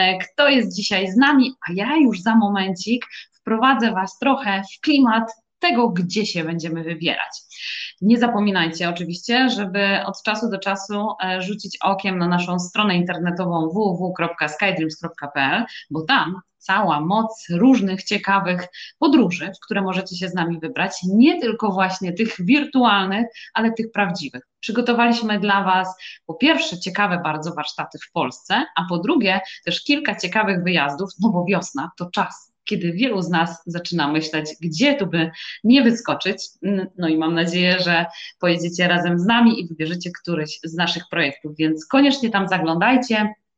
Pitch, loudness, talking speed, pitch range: 190 Hz, -20 LUFS, 150 wpm, 170-225 Hz